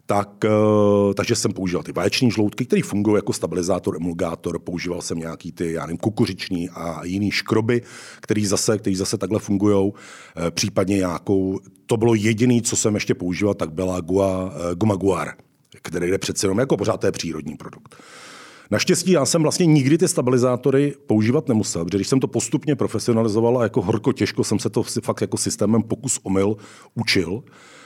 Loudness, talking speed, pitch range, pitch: -21 LUFS, 170 wpm, 95-120 Hz, 105 Hz